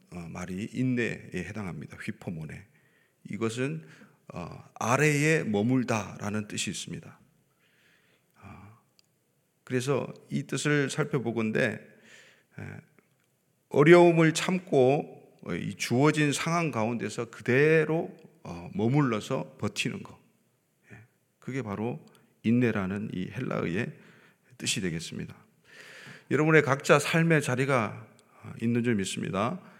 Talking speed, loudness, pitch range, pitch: 230 characters per minute, -27 LUFS, 115-155 Hz, 130 Hz